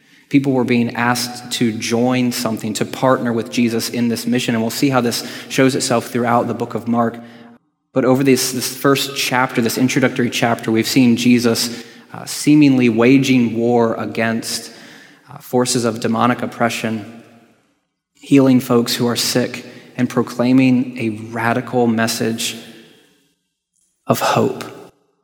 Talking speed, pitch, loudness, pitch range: 145 wpm, 120 Hz, -16 LUFS, 115-125 Hz